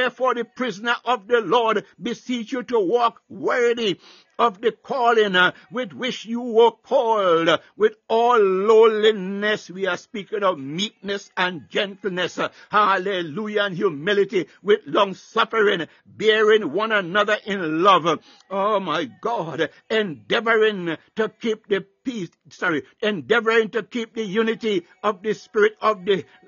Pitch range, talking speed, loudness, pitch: 195-235 Hz, 130 wpm, -21 LUFS, 215 Hz